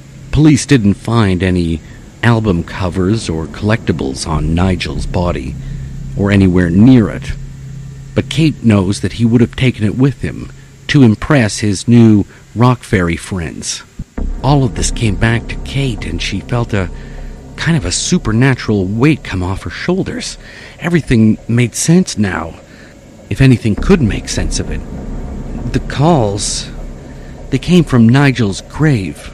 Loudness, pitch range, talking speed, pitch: -13 LUFS, 90-135 Hz, 145 wpm, 110 Hz